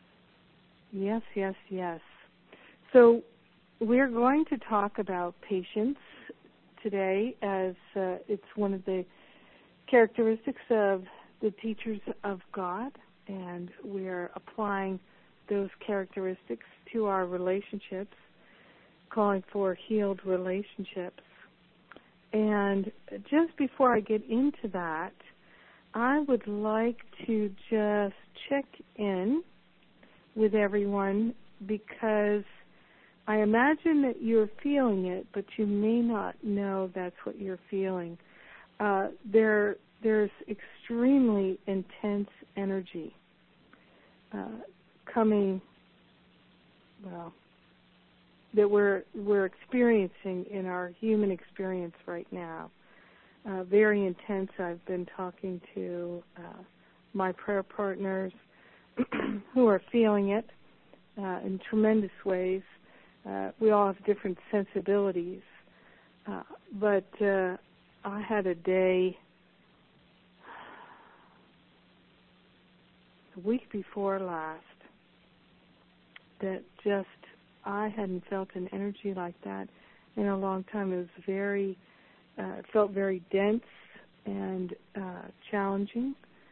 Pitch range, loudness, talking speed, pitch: 185-215 Hz, -30 LUFS, 100 wpm, 200 Hz